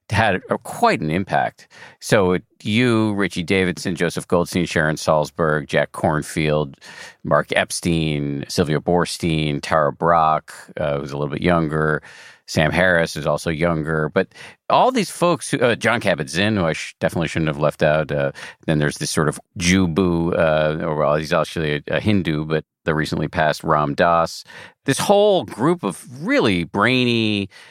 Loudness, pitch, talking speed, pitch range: -19 LUFS, 85 Hz, 160 wpm, 75-95 Hz